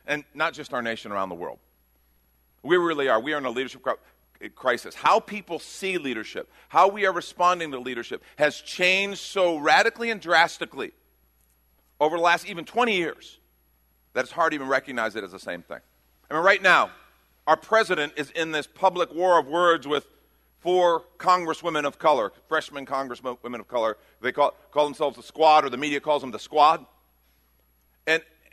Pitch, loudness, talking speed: 150 Hz, -24 LUFS, 180 wpm